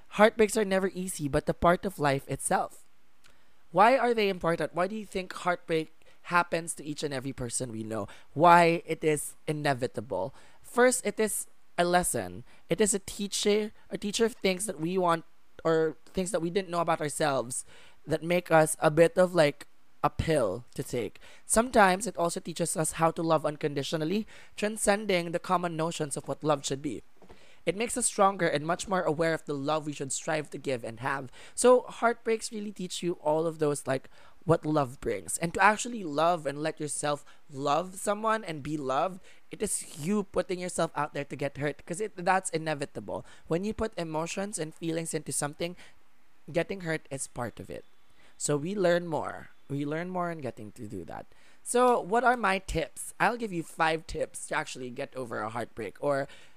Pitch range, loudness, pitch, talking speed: 145-190 Hz, -29 LUFS, 165 Hz, 195 wpm